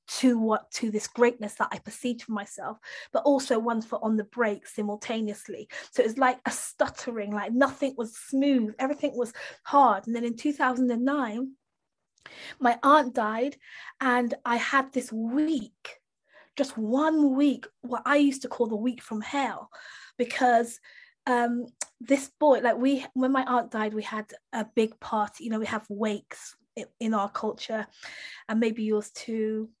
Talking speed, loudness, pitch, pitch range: 165 wpm, -27 LUFS, 240 Hz, 220-270 Hz